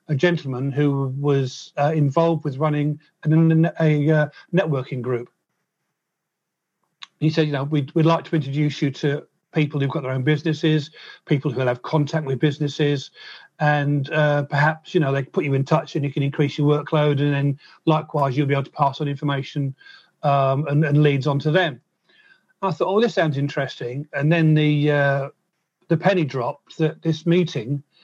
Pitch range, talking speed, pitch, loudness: 140-160 Hz, 185 wpm, 150 Hz, -21 LUFS